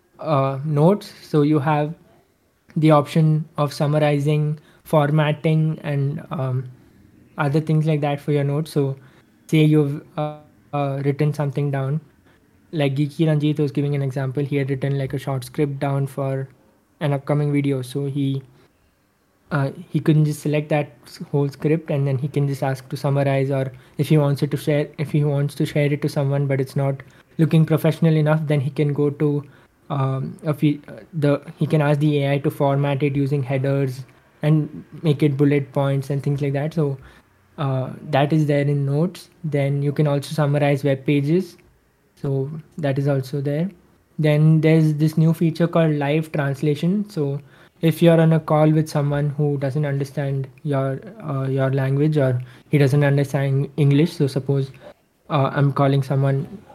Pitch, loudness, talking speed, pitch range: 145 Hz, -21 LUFS, 175 wpm, 140-155 Hz